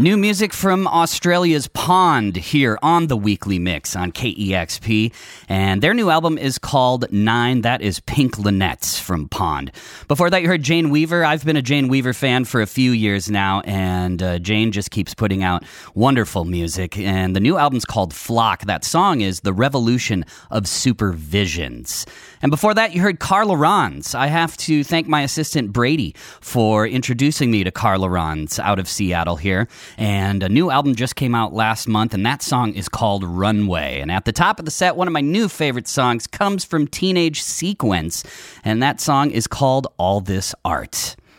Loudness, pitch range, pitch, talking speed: -18 LUFS, 95-145 Hz, 115 Hz, 185 wpm